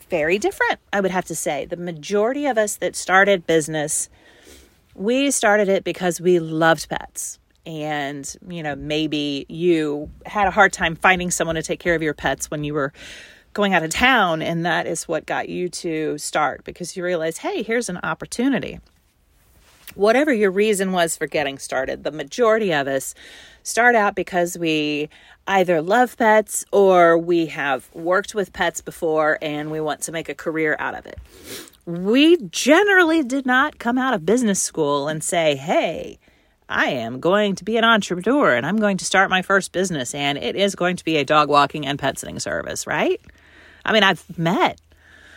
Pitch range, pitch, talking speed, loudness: 155-205 Hz, 175 Hz, 185 wpm, -20 LUFS